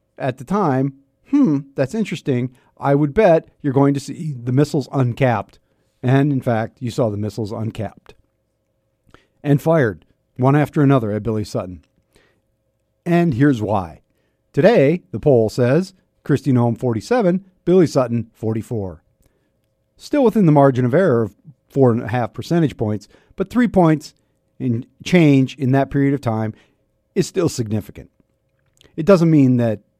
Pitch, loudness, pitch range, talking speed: 135 Hz, -18 LUFS, 110-150 Hz, 145 wpm